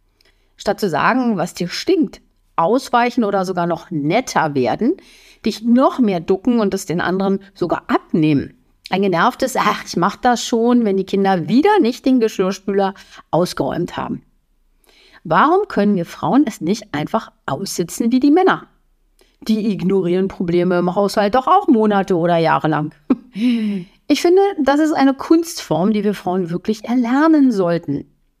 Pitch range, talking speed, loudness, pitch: 180-250 Hz, 150 wpm, -17 LUFS, 205 Hz